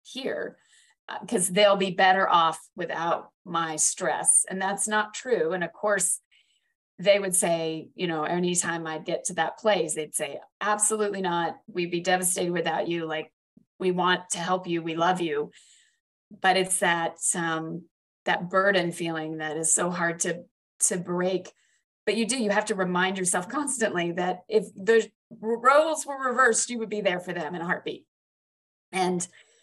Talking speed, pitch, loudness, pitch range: 170 wpm, 185 Hz, -25 LUFS, 170-210 Hz